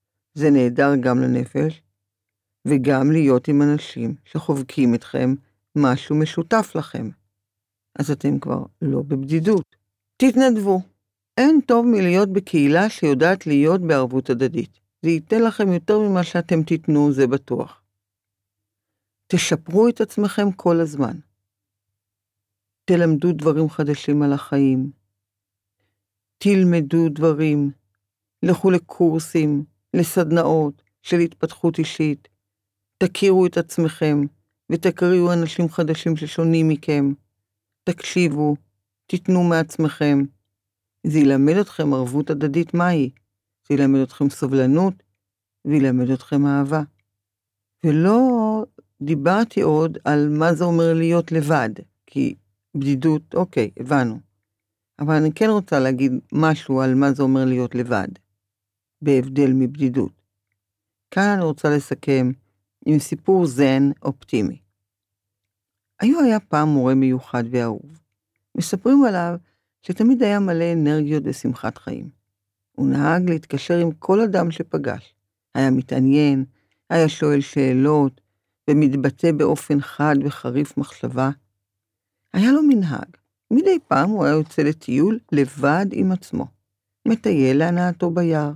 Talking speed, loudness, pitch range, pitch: 110 wpm, -19 LUFS, 105-165 Hz, 145 Hz